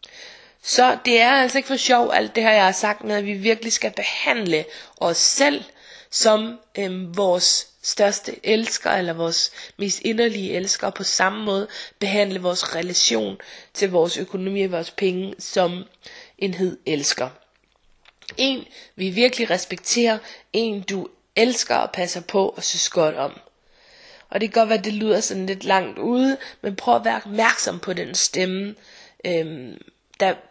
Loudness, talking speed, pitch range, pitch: -21 LUFS, 165 wpm, 185-225 Hz, 200 Hz